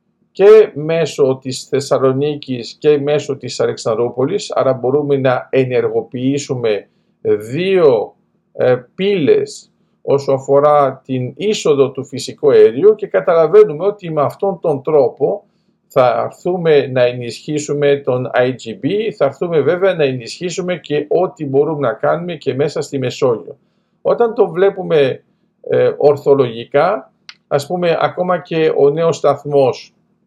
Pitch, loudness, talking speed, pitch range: 155 Hz, -15 LUFS, 120 wpm, 140-210 Hz